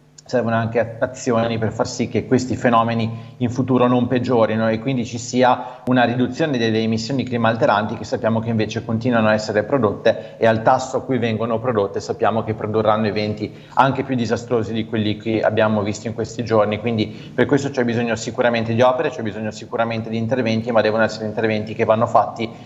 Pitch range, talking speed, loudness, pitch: 110-125 Hz, 195 wpm, -19 LUFS, 115 Hz